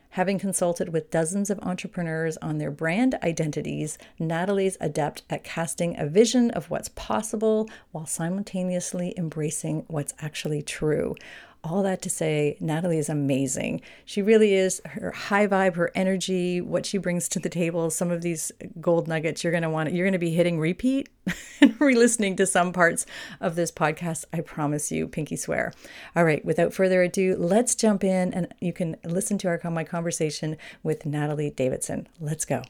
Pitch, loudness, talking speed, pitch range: 175 Hz, -25 LUFS, 175 wpm, 160-190 Hz